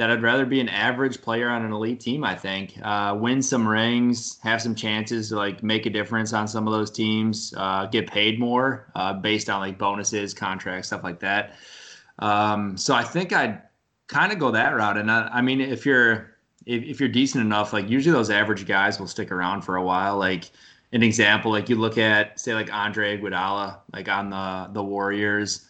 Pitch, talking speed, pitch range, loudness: 105 Hz, 210 wpm, 100-115 Hz, -23 LUFS